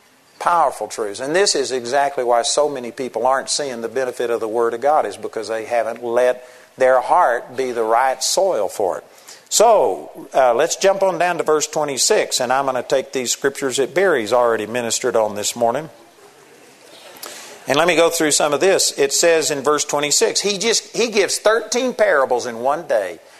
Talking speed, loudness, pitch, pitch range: 195 wpm, -18 LUFS, 140 Hz, 120-170 Hz